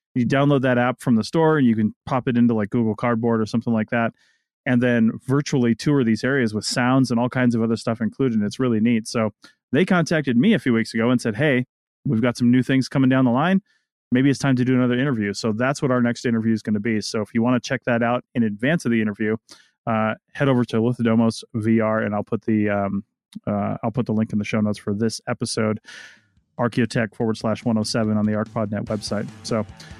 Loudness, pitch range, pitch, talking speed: -21 LUFS, 110-125 Hz, 115 Hz, 245 wpm